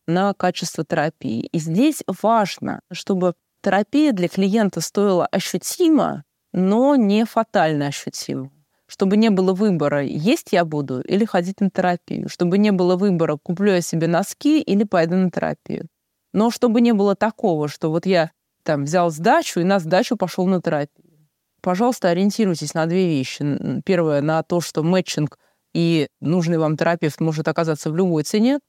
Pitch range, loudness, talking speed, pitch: 160-205 Hz, -20 LUFS, 155 wpm, 180 Hz